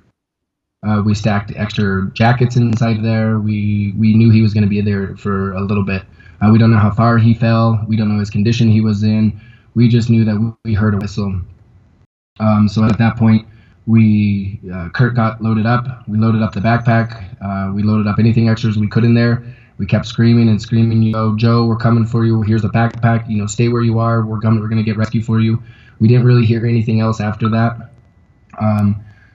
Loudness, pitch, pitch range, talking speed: -14 LUFS, 110 Hz, 105-115 Hz, 225 wpm